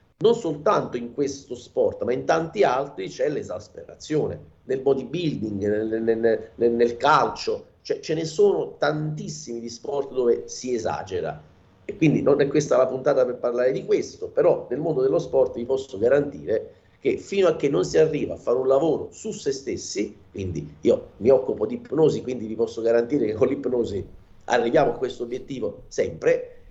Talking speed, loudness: 180 wpm, -24 LUFS